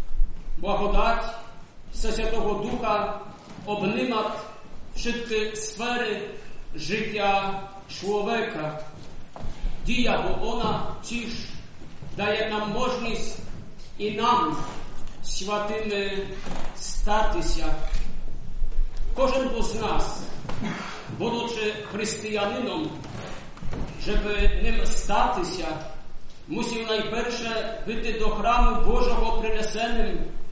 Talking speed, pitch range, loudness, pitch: 70 wpm, 205-225 Hz, -28 LUFS, 215 Hz